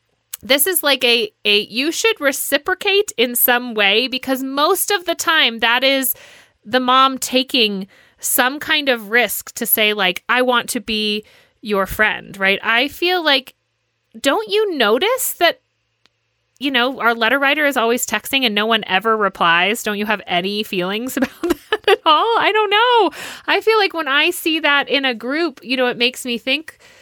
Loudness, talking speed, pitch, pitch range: -16 LUFS, 185 wpm, 255 Hz, 215-320 Hz